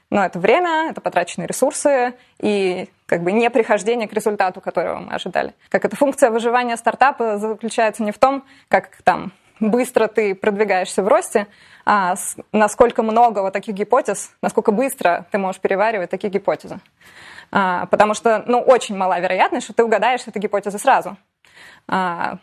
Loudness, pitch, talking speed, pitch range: -18 LUFS, 215 Hz, 160 wpm, 200-245 Hz